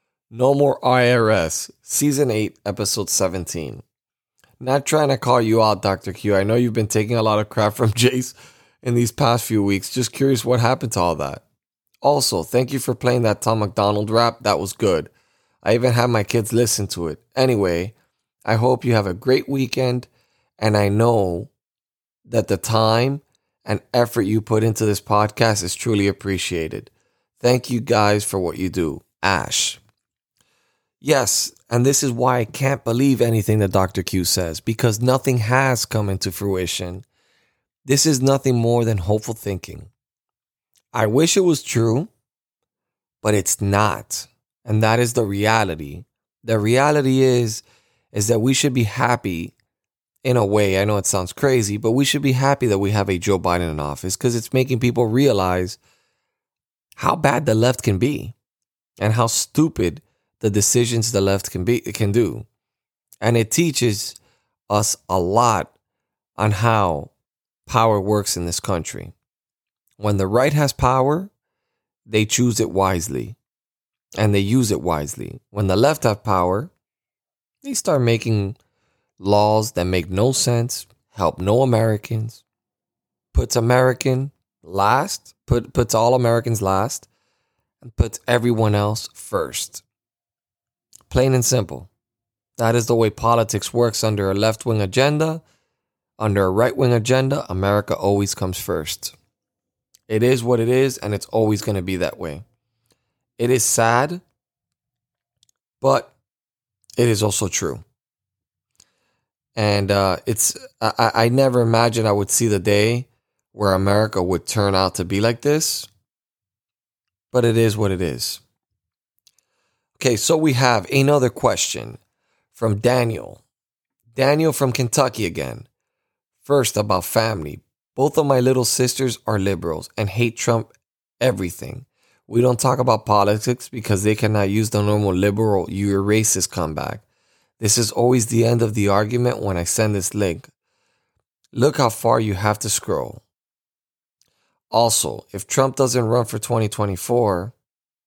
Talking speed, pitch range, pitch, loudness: 150 wpm, 100-125 Hz, 115 Hz, -19 LUFS